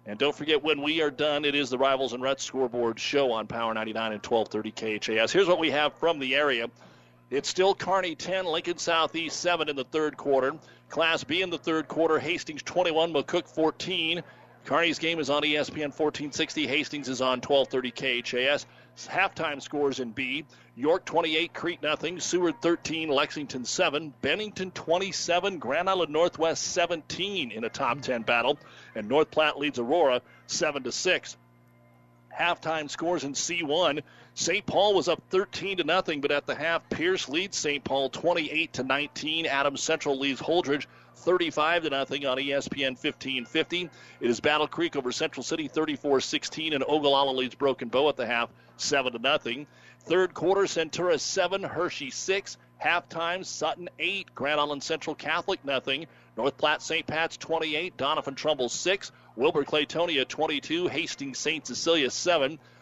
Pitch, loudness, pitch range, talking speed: 150 Hz, -27 LUFS, 135-170 Hz, 165 wpm